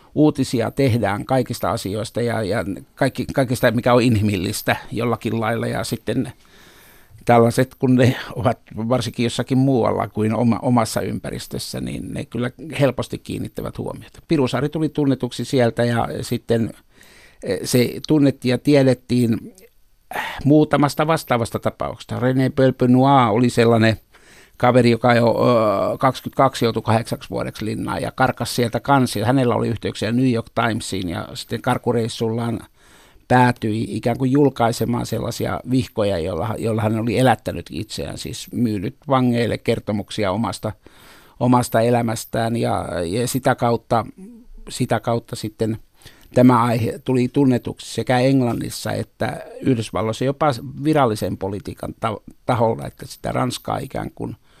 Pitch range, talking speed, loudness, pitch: 115-130 Hz, 120 wpm, -20 LUFS, 120 Hz